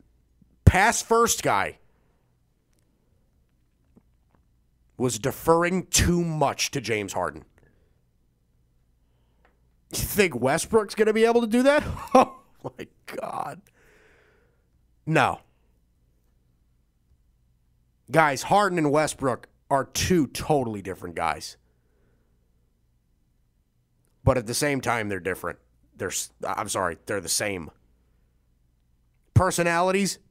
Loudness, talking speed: -24 LUFS, 90 wpm